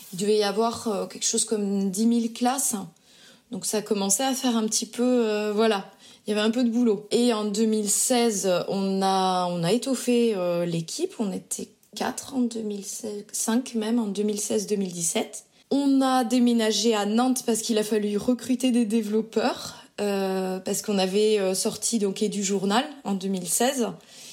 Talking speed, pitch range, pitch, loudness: 170 wpm, 200-240 Hz, 220 Hz, -25 LUFS